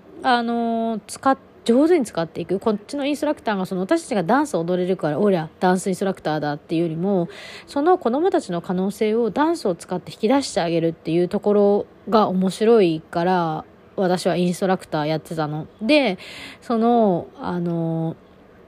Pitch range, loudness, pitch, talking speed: 170-235 Hz, -21 LUFS, 195 Hz, 390 characters per minute